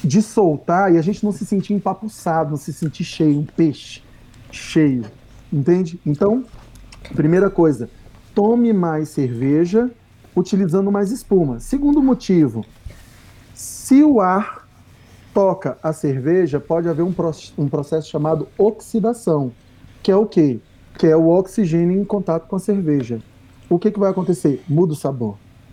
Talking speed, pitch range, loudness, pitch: 145 wpm, 130-195 Hz, -18 LUFS, 165 Hz